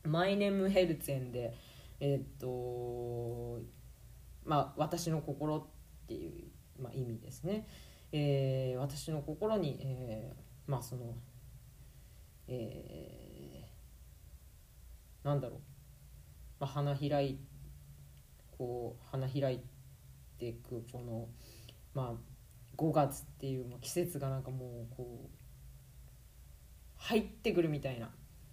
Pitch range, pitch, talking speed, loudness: 115-140 Hz, 130 Hz, 200 characters per minute, -38 LUFS